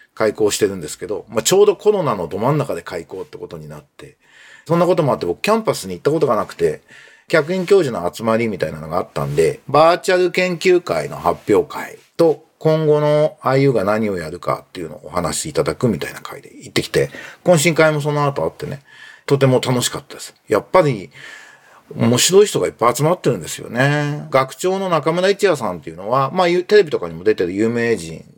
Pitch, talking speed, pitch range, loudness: 165 Hz, 425 characters per minute, 135-205 Hz, -17 LUFS